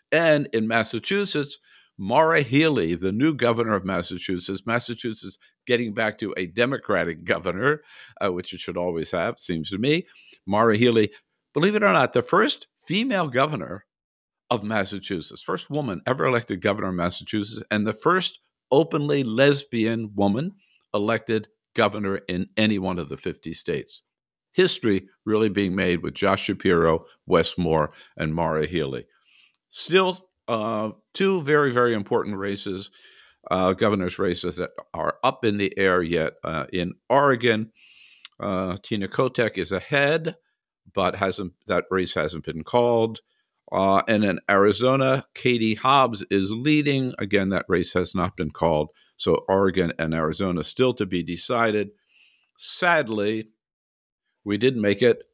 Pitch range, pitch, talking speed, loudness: 95-120 Hz, 105 Hz, 145 wpm, -23 LUFS